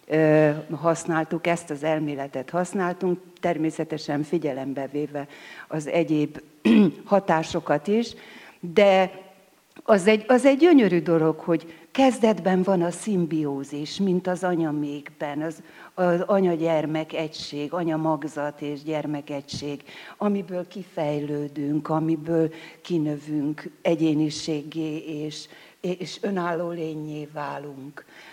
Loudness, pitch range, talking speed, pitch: -24 LUFS, 150-180 Hz, 95 wpm, 160 Hz